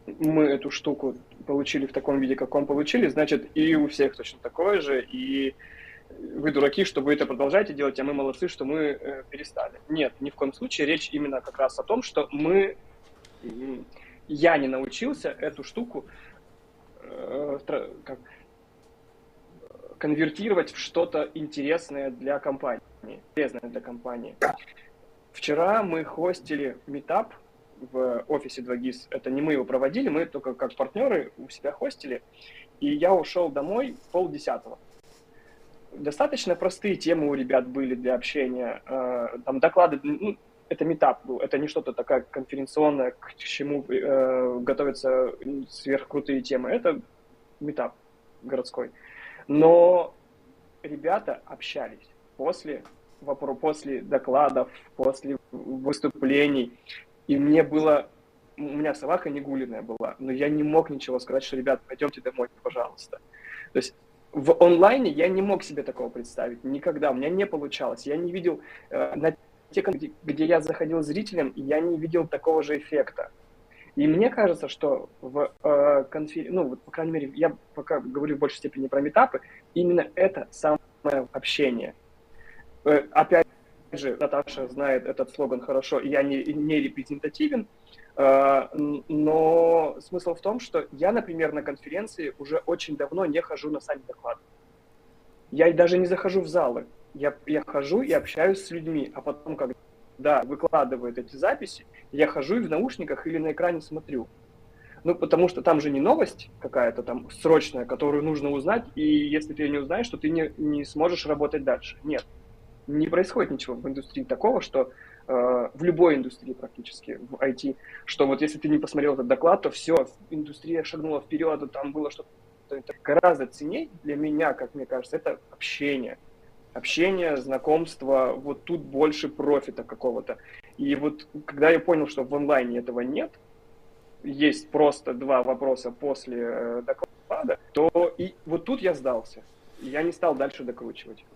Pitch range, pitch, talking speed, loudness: 135-170 Hz, 150 Hz, 150 wpm, -26 LUFS